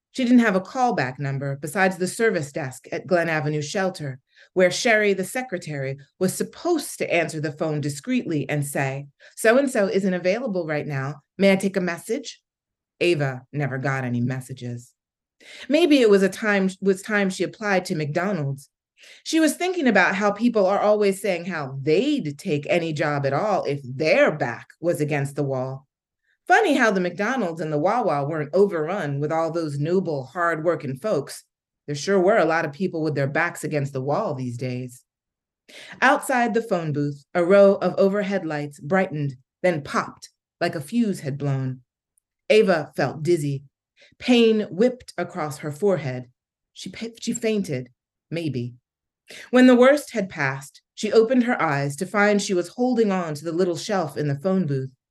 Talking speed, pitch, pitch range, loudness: 175 wpm, 170 Hz, 145-200 Hz, -22 LUFS